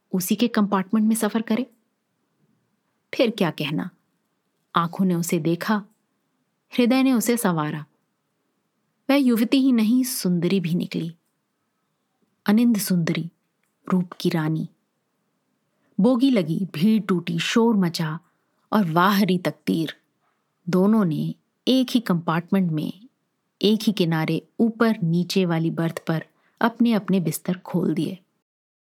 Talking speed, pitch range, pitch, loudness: 120 wpm, 175-230 Hz, 195 Hz, -22 LUFS